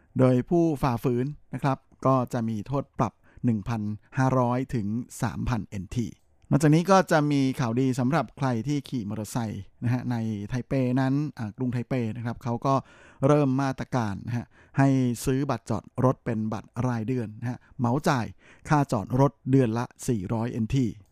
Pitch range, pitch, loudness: 115-135 Hz, 125 Hz, -27 LUFS